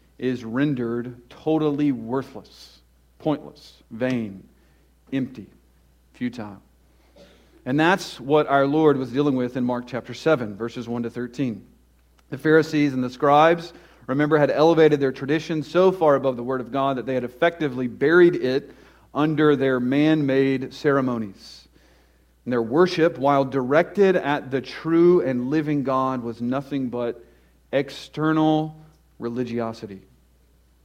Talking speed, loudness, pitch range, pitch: 130 wpm, -22 LUFS, 115-150 Hz, 130 Hz